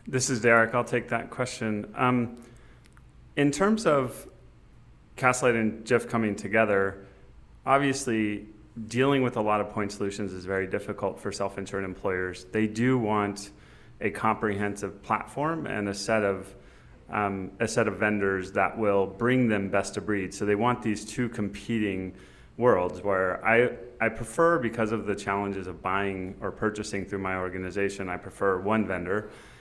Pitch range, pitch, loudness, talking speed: 100-120 Hz, 105 Hz, -27 LUFS, 160 wpm